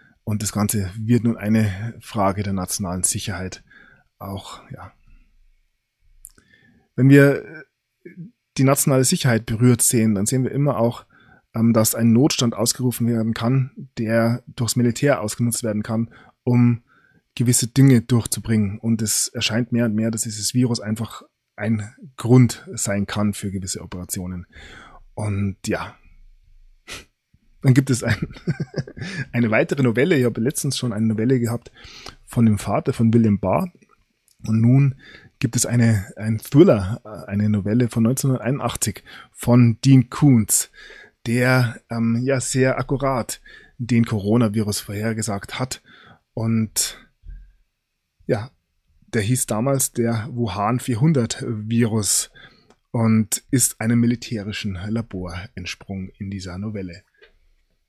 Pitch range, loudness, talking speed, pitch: 105-125 Hz, -20 LUFS, 125 wpm, 115 Hz